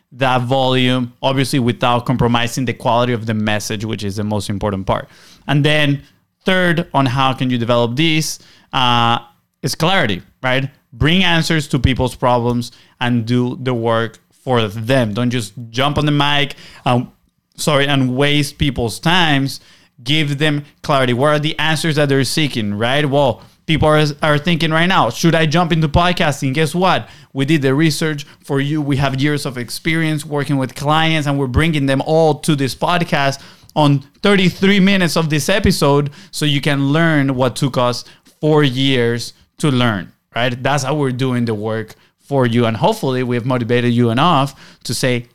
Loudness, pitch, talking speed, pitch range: -16 LUFS, 140 Hz, 175 wpm, 125-155 Hz